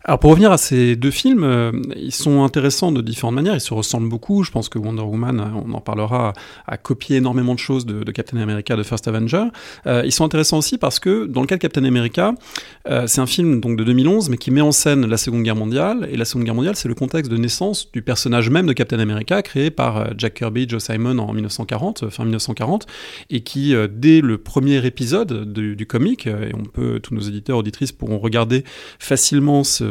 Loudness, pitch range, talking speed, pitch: -18 LUFS, 115-145 Hz, 230 wpm, 125 Hz